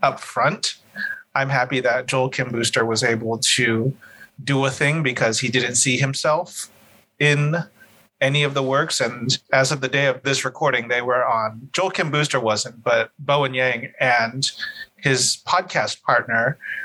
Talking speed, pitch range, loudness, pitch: 165 wpm, 120-140 Hz, -20 LUFS, 130 Hz